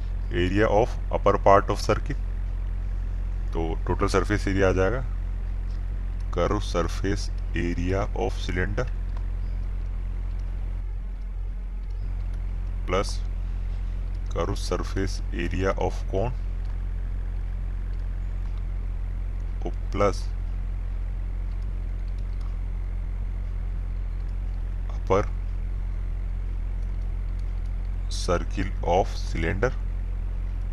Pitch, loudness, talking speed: 90 Hz, -29 LUFS, 55 wpm